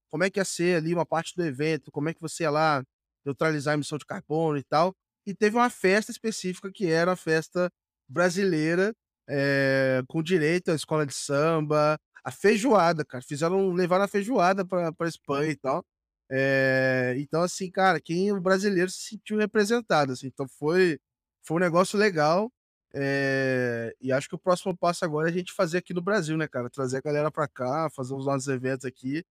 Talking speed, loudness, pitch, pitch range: 200 wpm, -26 LUFS, 160 Hz, 140-185 Hz